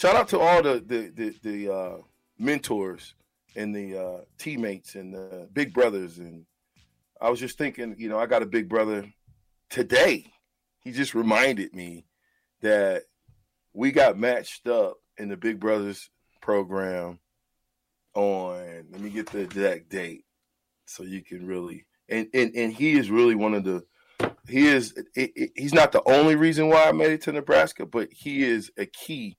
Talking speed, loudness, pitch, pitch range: 175 wpm, -24 LUFS, 105 Hz, 95-125 Hz